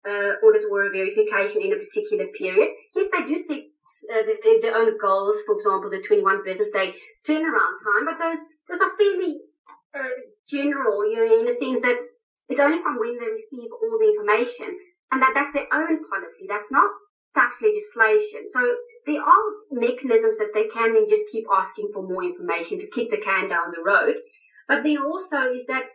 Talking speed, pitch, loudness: 190 wpm, 360 Hz, -22 LUFS